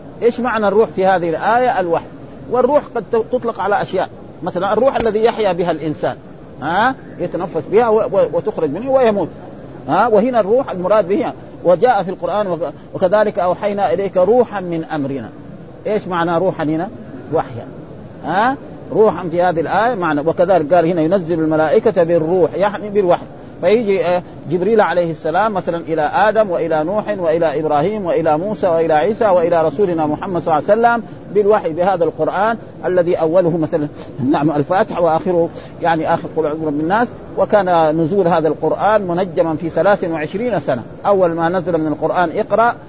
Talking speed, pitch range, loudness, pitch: 155 wpm, 160-210 Hz, -16 LUFS, 175 Hz